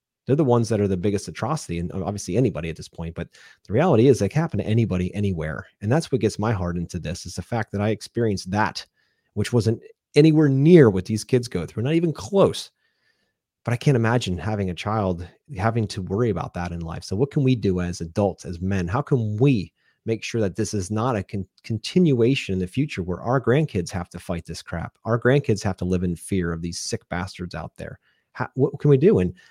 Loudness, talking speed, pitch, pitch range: -23 LUFS, 235 wpm, 105 Hz, 90-125 Hz